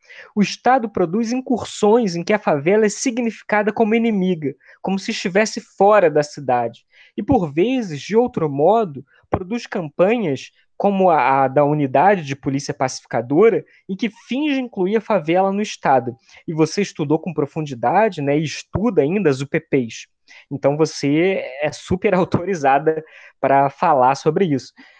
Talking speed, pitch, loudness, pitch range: 150 wpm, 185 Hz, -19 LUFS, 145-215 Hz